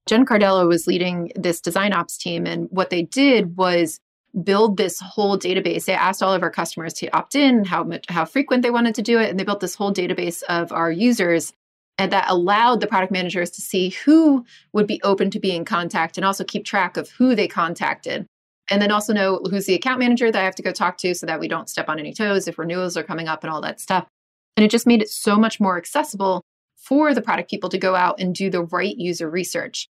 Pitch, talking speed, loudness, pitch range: 190 Hz, 245 wpm, -20 LUFS, 175-210 Hz